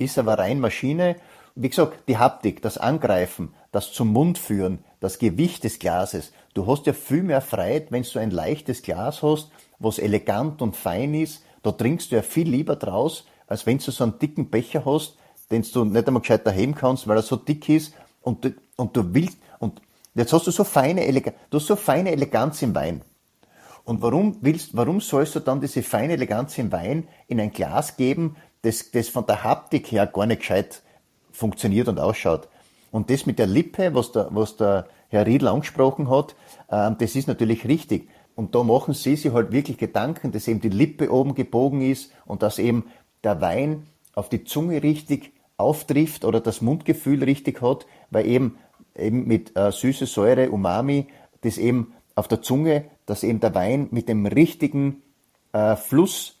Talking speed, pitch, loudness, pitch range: 190 wpm, 130 Hz, -23 LUFS, 115-150 Hz